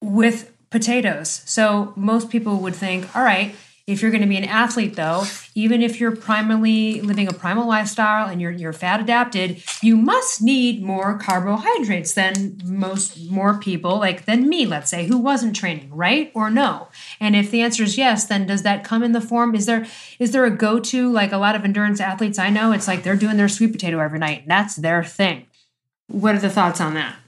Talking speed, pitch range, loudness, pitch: 210 wpm, 190-230 Hz, -19 LUFS, 210 Hz